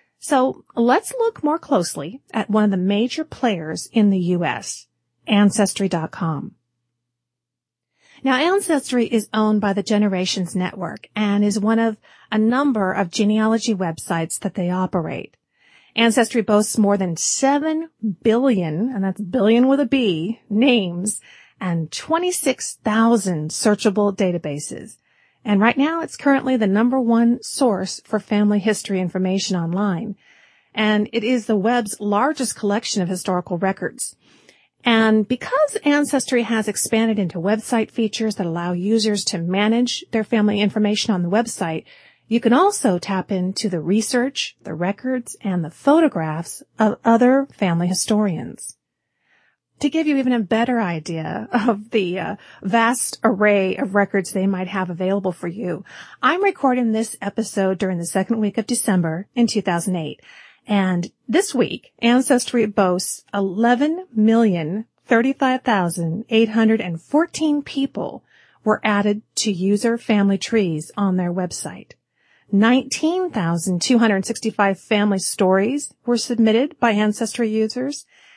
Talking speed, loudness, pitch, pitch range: 130 wpm, -20 LUFS, 215 Hz, 190-240 Hz